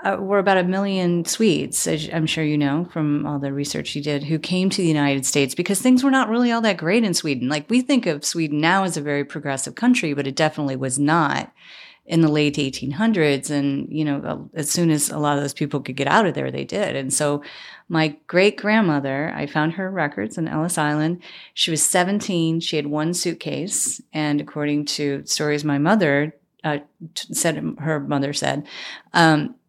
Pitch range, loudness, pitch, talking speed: 145-185 Hz, -21 LUFS, 155 Hz, 210 wpm